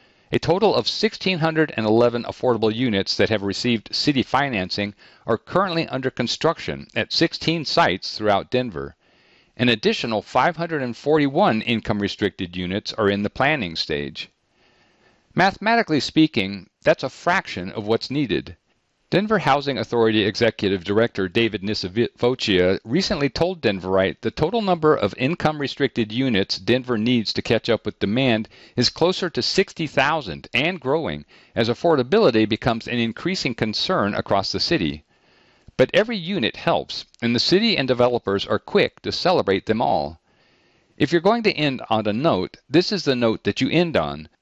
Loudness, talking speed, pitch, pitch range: -21 LUFS, 145 wpm, 120 Hz, 105-155 Hz